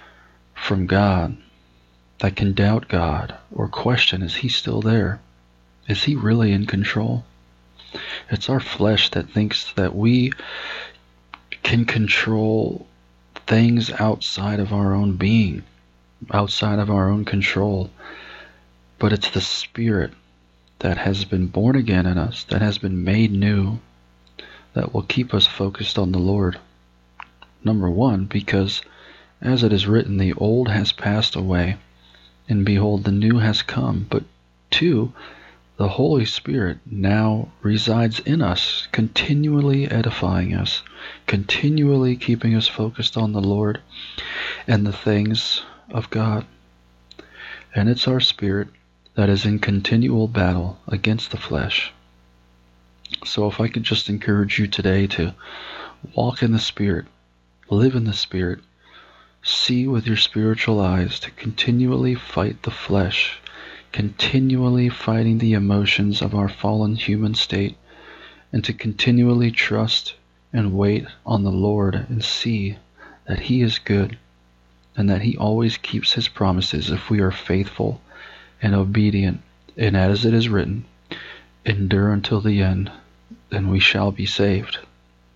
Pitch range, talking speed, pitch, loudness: 90-110 Hz, 135 wpm, 100 Hz, -20 LUFS